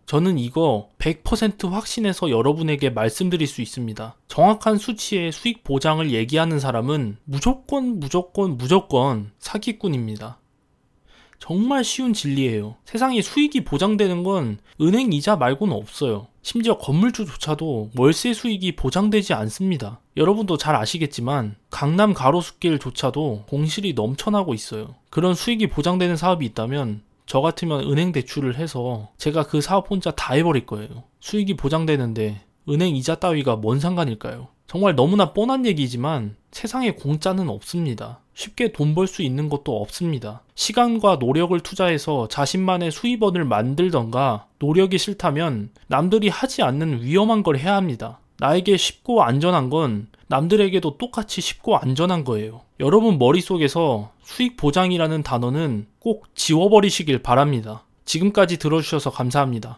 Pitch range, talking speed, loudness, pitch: 130-195 Hz, 345 characters per minute, -21 LUFS, 160 Hz